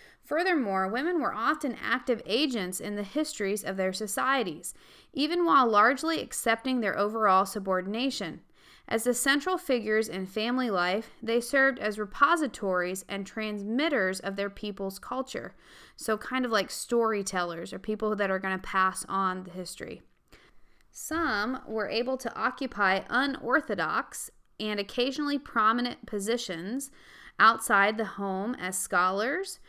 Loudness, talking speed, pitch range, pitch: -28 LUFS, 135 wpm, 195-260 Hz, 220 Hz